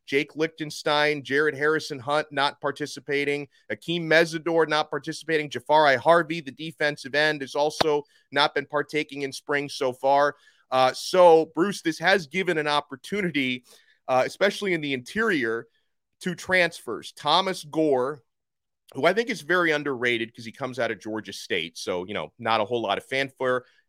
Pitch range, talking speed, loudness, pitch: 135-160 Hz, 160 wpm, -24 LUFS, 150 Hz